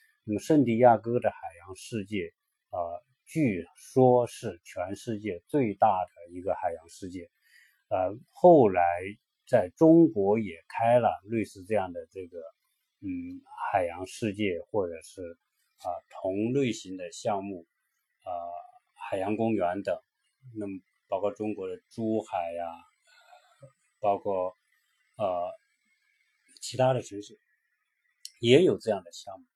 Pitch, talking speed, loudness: 110 Hz, 190 characters per minute, -28 LUFS